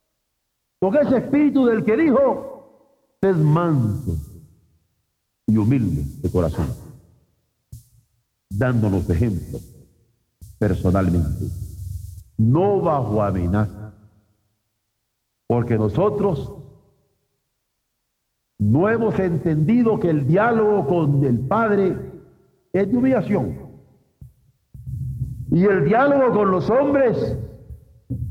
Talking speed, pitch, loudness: 80 wpm, 125 Hz, -20 LUFS